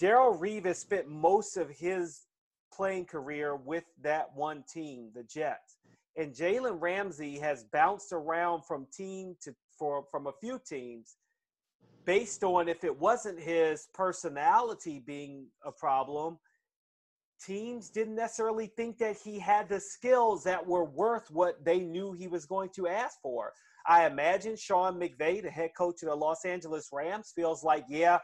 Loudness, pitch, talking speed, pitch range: -32 LUFS, 175 Hz, 155 wpm, 155-205 Hz